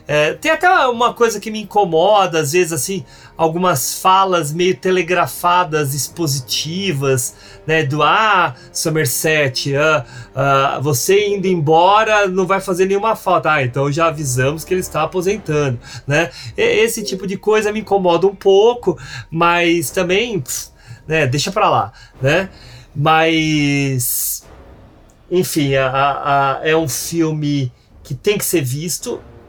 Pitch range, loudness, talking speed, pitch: 140-190 Hz, -16 LUFS, 140 wpm, 160 Hz